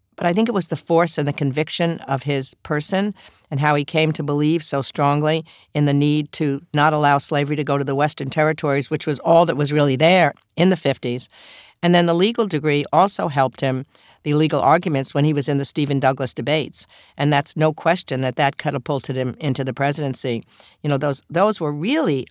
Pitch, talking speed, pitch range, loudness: 150 Hz, 215 wpm, 140-160 Hz, -20 LUFS